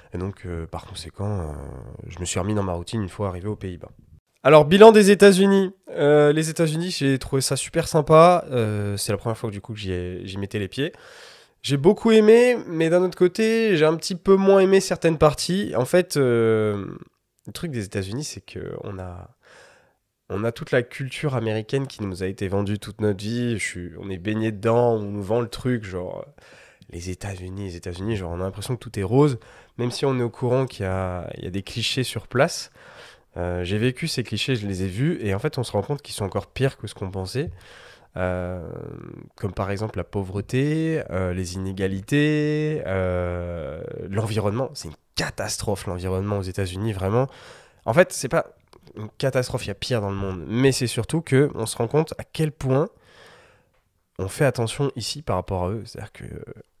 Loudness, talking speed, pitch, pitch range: -22 LUFS, 210 wpm, 110 Hz, 95-145 Hz